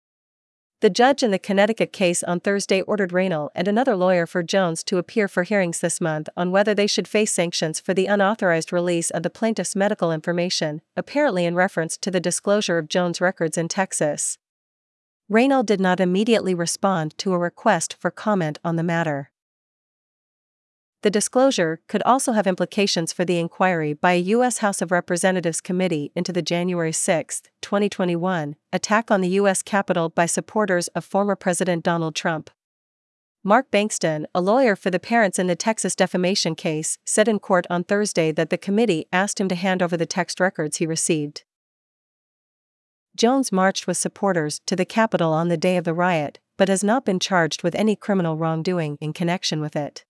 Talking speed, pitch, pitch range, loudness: 180 wpm, 185 Hz, 170-205 Hz, -21 LUFS